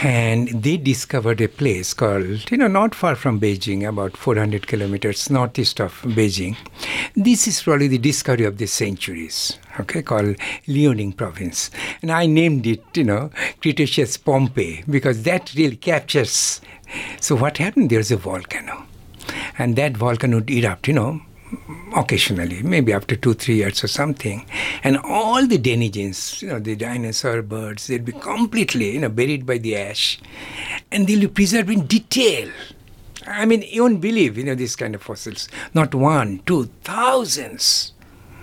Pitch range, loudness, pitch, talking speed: 105-155 Hz, -19 LUFS, 125 Hz, 160 wpm